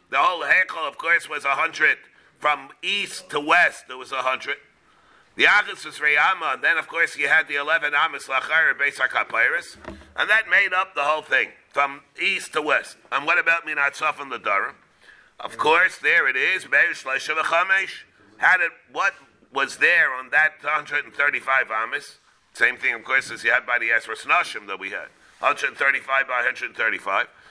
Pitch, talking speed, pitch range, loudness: 150 Hz, 180 wpm, 140-165 Hz, -21 LUFS